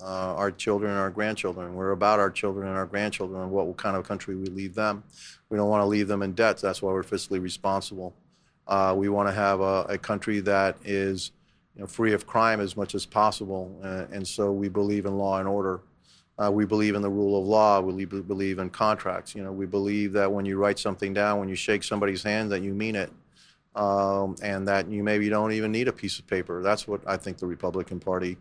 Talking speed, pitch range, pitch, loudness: 240 wpm, 95-105 Hz, 100 Hz, -27 LUFS